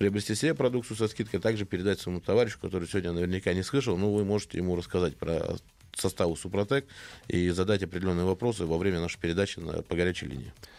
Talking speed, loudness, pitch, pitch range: 190 wpm, -30 LUFS, 95 Hz, 90-105 Hz